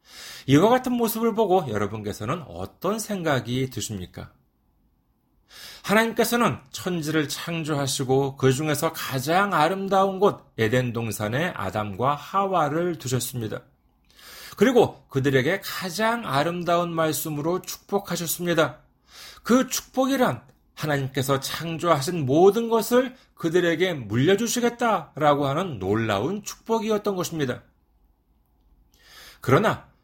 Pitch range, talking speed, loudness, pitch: 130-195 Hz, 270 characters per minute, -24 LUFS, 160 Hz